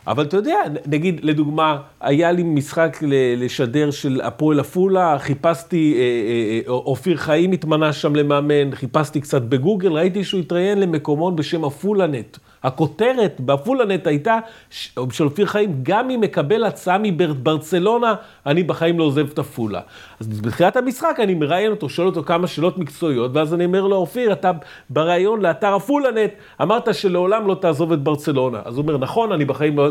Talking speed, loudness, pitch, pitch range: 155 wpm, -19 LUFS, 160 Hz, 145-190 Hz